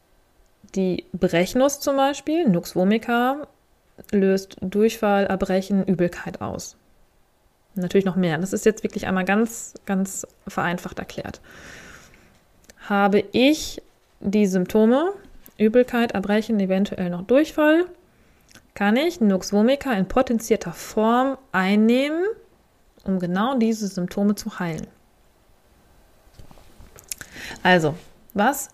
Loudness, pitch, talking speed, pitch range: -22 LUFS, 205 Hz, 100 wpm, 190-245 Hz